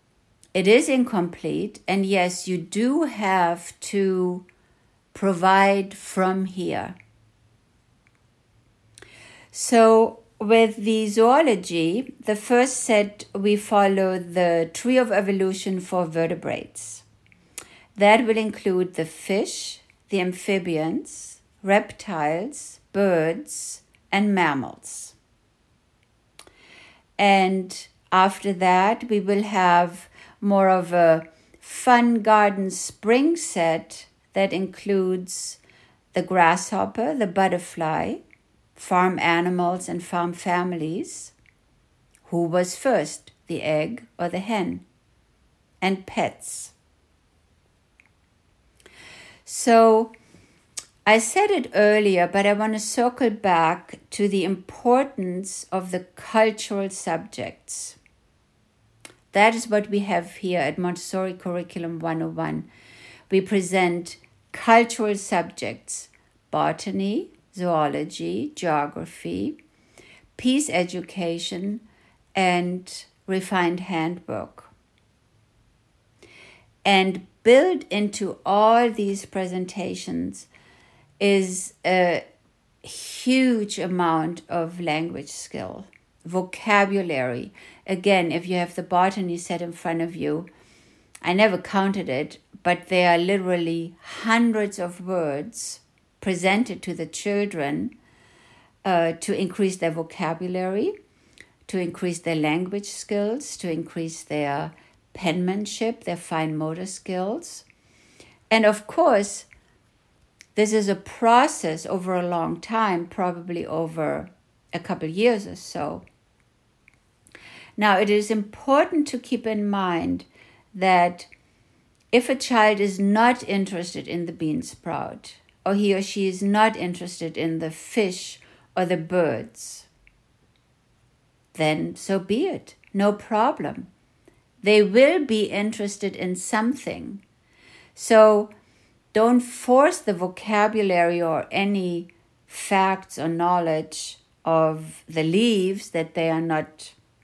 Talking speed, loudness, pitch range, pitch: 100 wpm, -23 LUFS, 170-210 Hz, 185 Hz